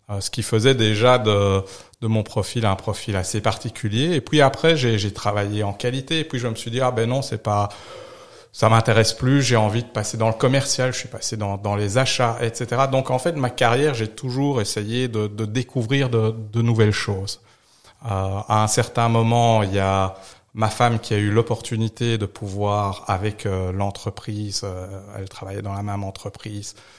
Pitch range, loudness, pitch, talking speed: 105-125 Hz, -21 LUFS, 110 Hz, 195 wpm